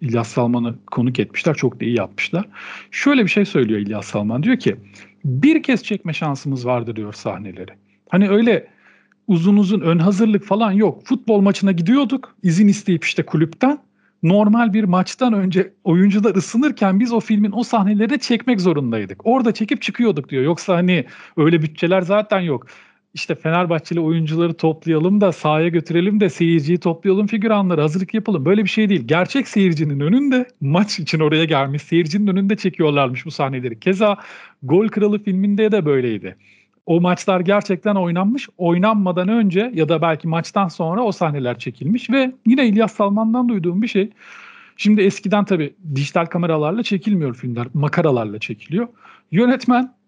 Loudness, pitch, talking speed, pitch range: -18 LUFS, 185 Hz, 155 wpm, 155-215 Hz